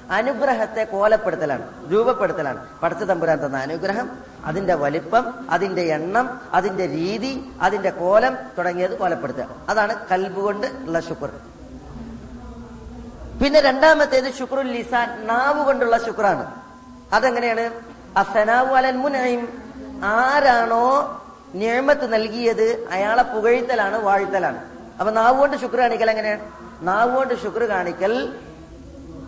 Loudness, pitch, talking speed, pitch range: -20 LUFS, 230 Hz, 95 wpm, 195-255 Hz